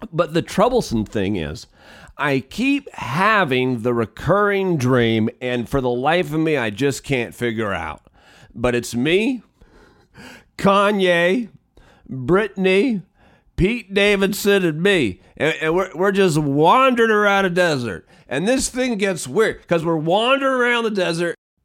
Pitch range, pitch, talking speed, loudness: 125-200 Hz, 170 Hz, 140 wpm, -19 LUFS